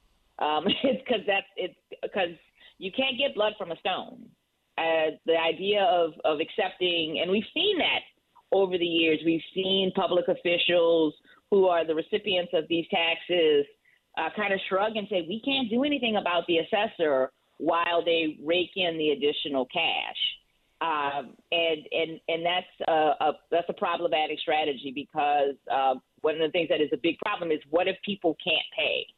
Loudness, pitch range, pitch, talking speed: -27 LUFS, 160-210 Hz, 175 Hz, 175 wpm